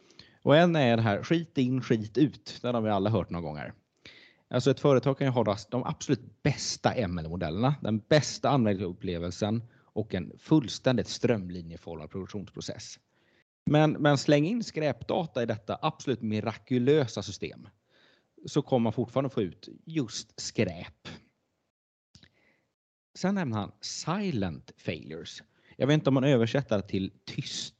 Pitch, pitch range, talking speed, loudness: 120 Hz, 105-140 Hz, 140 wpm, -29 LUFS